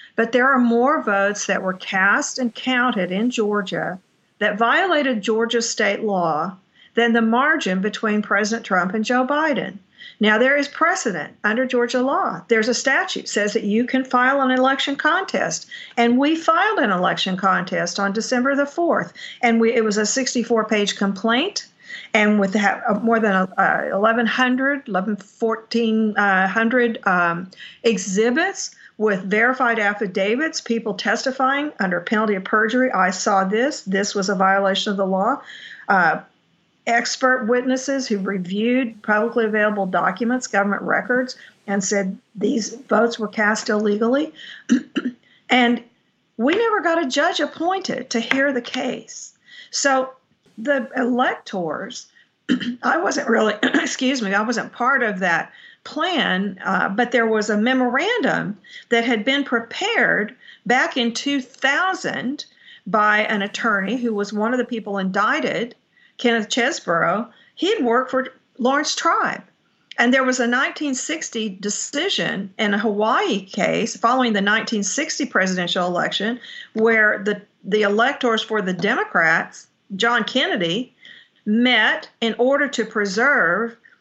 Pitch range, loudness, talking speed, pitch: 210-260 Hz, -20 LUFS, 135 wpm, 230 Hz